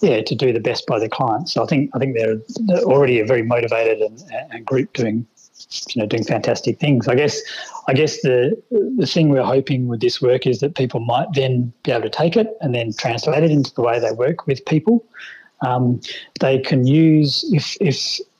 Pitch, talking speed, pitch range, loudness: 135 Hz, 220 wpm, 120-155 Hz, -18 LUFS